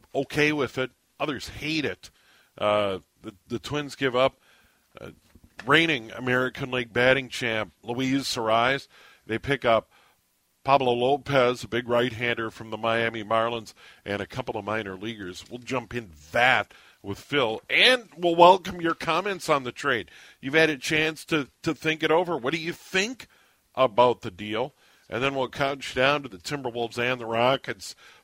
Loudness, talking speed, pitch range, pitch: -25 LUFS, 170 wpm, 115-145 Hz, 125 Hz